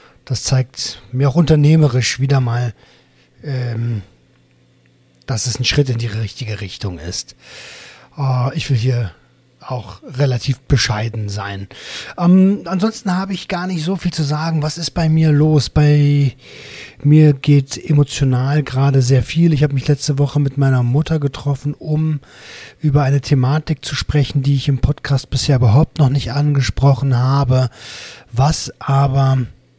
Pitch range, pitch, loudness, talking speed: 125-150 Hz, 140 Hz, -16 LUFS, 145 wpm